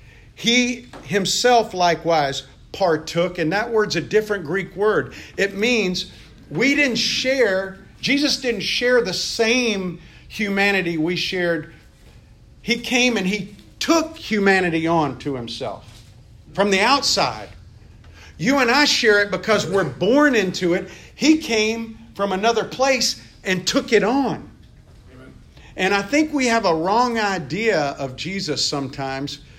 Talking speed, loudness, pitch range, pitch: 135 wpm, -19 LUFS, 160-230 Hz, 195 Hz